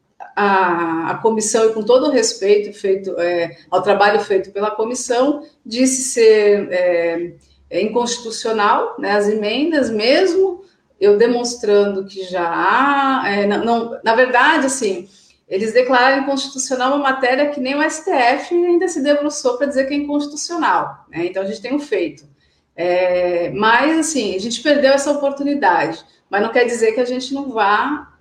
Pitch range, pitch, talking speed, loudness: 200-280 Hz, 240 Hz, 160 wpm, -16 LUFS